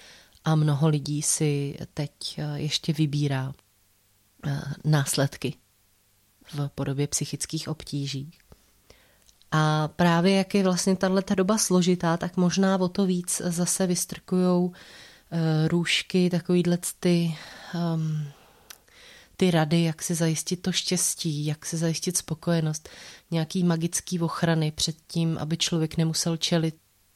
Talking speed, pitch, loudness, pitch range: 110 wpm, 165 Hz, -25 LUFS, 150-180 Hz